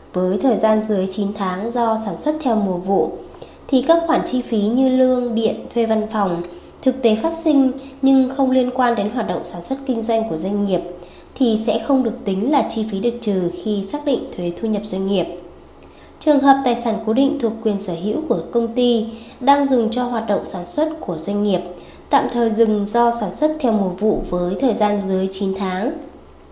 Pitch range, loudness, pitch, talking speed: 200-255 Hz, -19 LUFS, 225 Hz, 220 wpm